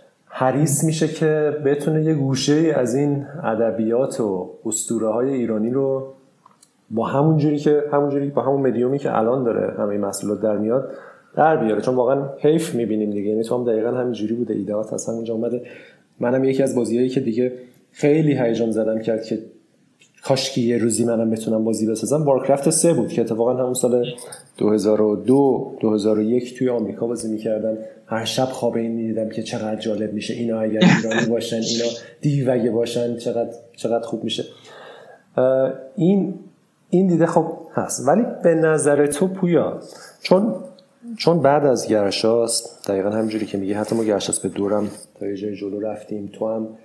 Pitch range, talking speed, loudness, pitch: 110-140 Hz, 170 wpm, -20 LUFS, 120 Hz